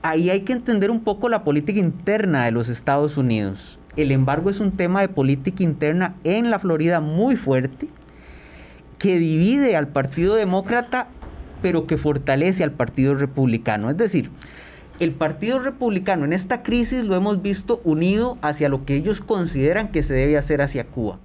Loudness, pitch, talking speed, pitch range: -21 LUFS, 165 Hz, 170 wpm, 140-205 Hz